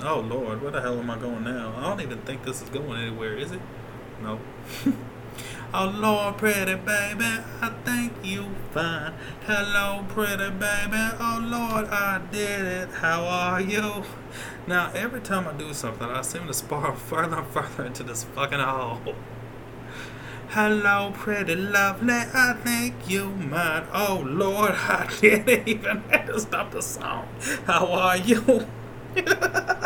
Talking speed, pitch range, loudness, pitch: 155 wpm, 130-210 Hz, -25 LUFS, 180 Hz